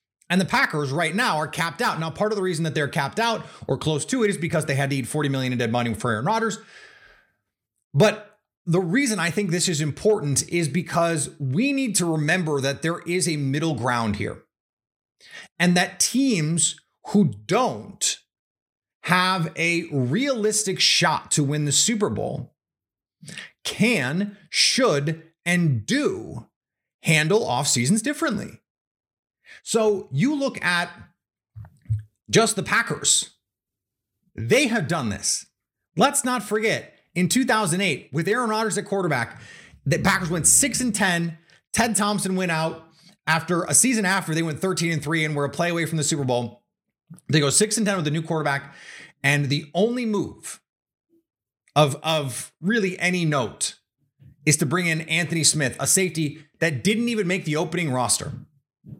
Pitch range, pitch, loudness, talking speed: 145-205 Hz, 170 Hz, -22 LUFS, 165 wpm